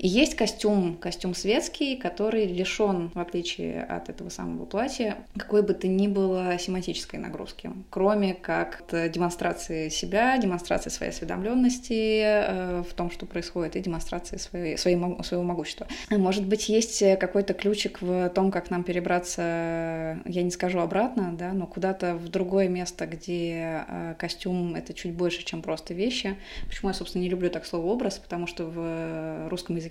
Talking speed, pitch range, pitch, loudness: 155 wpm, 170-200 Hz, 180 Hz, -28 LUFS